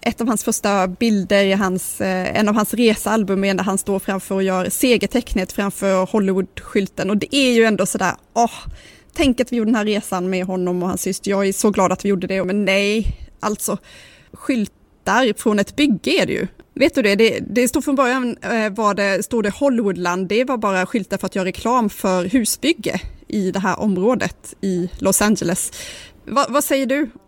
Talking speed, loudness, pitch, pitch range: 200 wpm, -19 LUFS, 205 Hz, 190-235 Hz